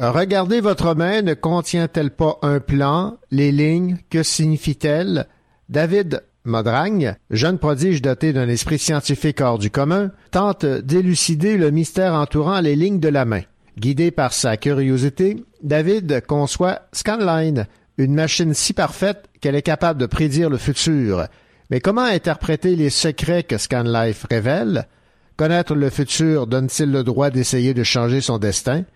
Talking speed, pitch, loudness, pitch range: 145 wpm, 150 Hz, -18 LUFS, 135-175 Hz